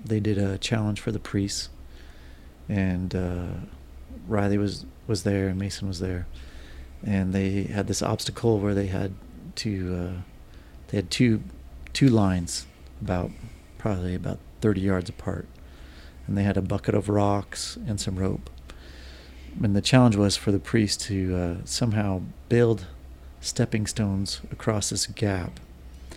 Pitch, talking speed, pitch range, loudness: 95 Hz, 145 wpm, 70-100 Hz, -26 LUFS